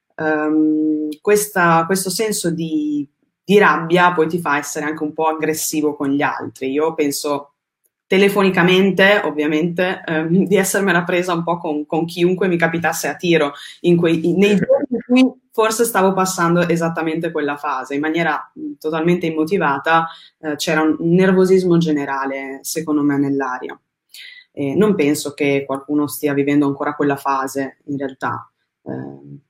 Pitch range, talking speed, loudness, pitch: 145-185 Hz, 145 wpm, -17 LUFS, 160 Hz